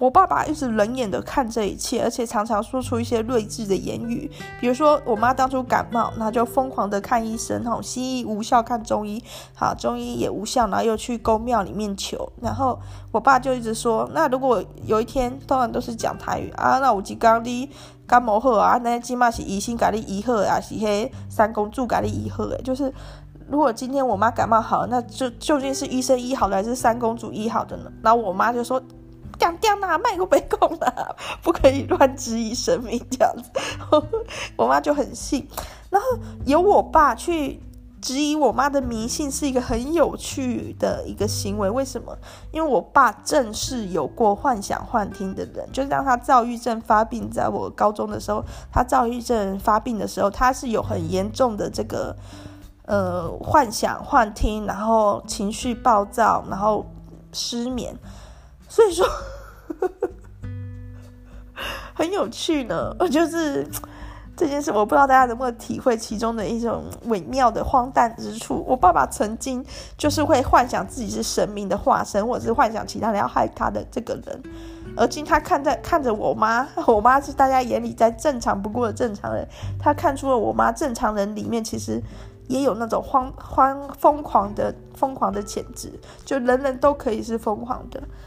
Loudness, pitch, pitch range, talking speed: -22 LUFS, 240 Hz, 215-270 Hz, 270 characters per minute